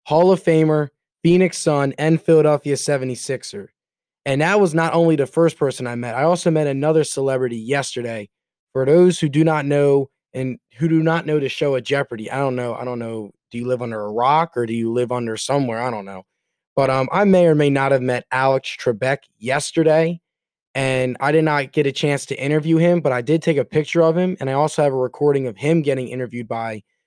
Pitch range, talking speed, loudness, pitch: 125-160 Hz, 225 wpm, -19 LUFS, 140 Hz